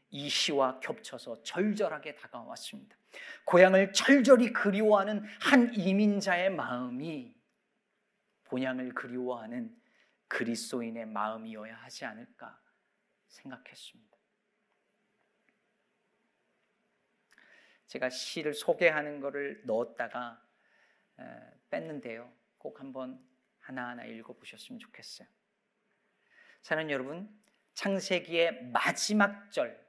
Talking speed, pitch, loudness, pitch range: 230 characters per minute, 190 Hz, -30 LUFS, 130-215 Hz